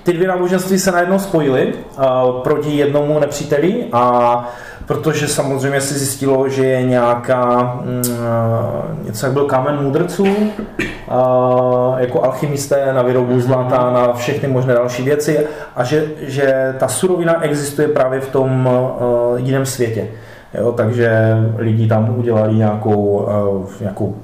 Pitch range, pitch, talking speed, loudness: 120-145 Hz, 130 Hz, 135 wpm, -15 LUFS